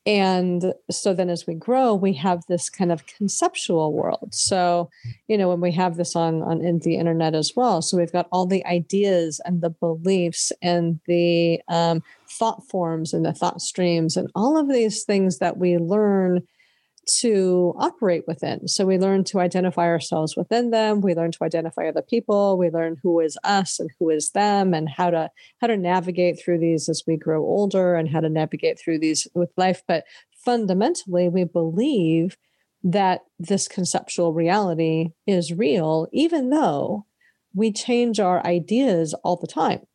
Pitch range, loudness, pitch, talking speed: 165-195 Hz, -22 LUFS, 180 Hz, 175 wpm